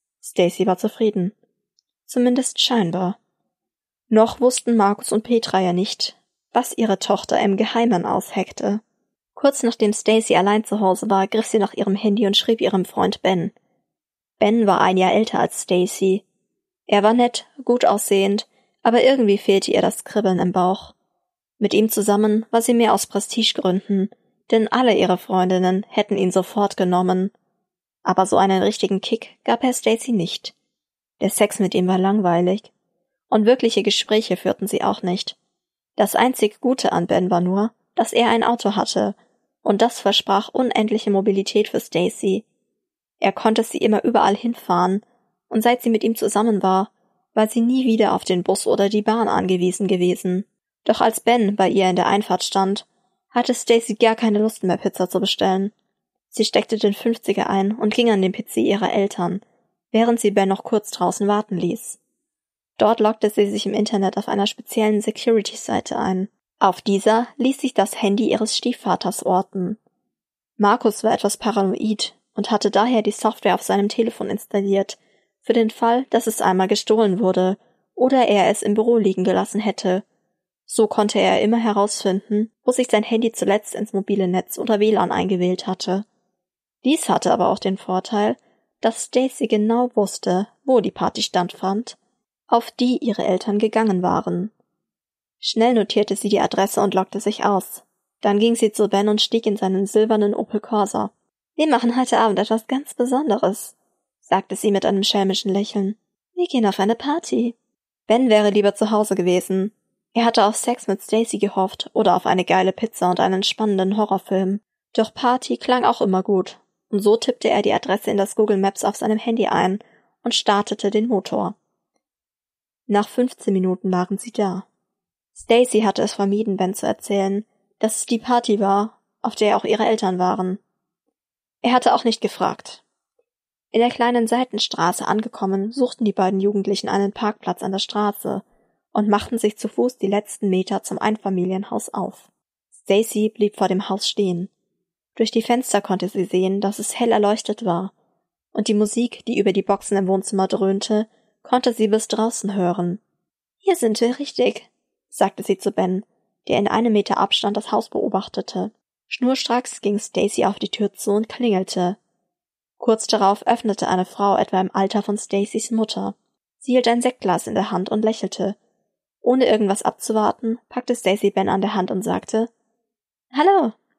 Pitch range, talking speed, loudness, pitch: 195-230 Hz, 170 wpm, -20 LUFS, 210 Hz